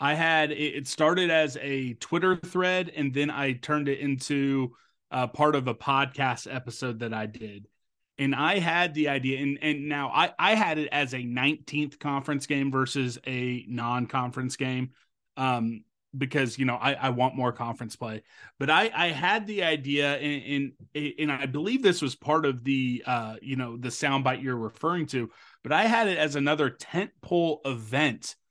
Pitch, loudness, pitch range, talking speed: 140 Hz, -27 LUFS, 125-150 Hz, 180 wpm